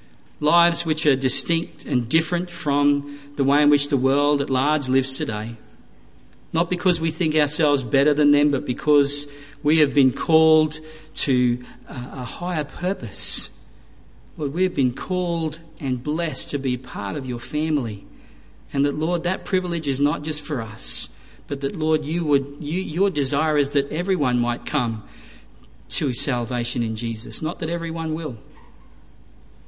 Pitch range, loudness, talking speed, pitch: 130-160 Hz, -22 LUFS, 160 wpm, 145 Hz